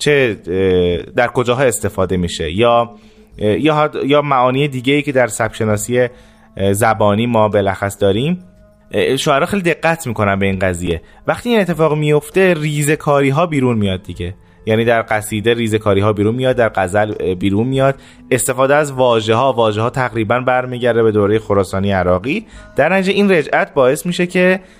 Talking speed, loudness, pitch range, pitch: 150 wpm, -15 LUFS, 105-140 Hz, 115 Hz